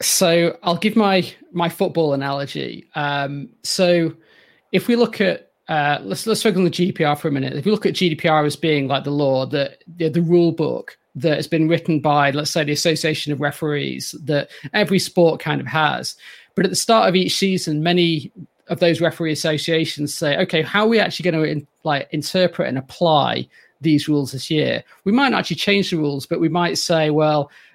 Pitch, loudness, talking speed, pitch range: 165 Hz, -19 LUFS, 205 wpm, 150-180 Hz